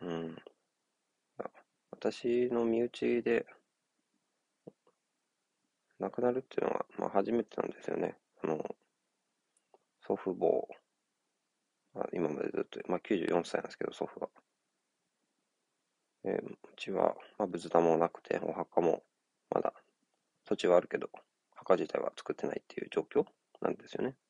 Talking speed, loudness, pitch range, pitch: 240 characters per minute, -35 LUFS, 85-120 Hz, 105 Hz